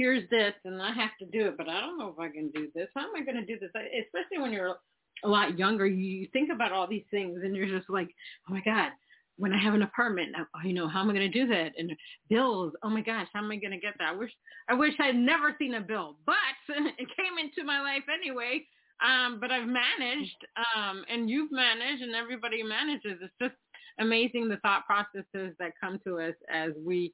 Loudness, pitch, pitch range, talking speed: -30 LUFS, 215 Hz, 190-250 Hz, 250 wpm